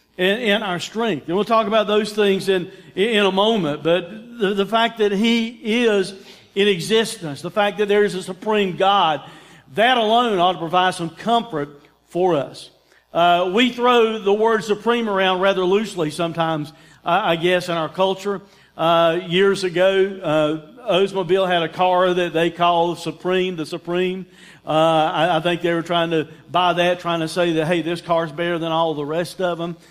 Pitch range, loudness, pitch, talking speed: 170-205 Hz, -19 LUFS, 185 Hz, 185 wpm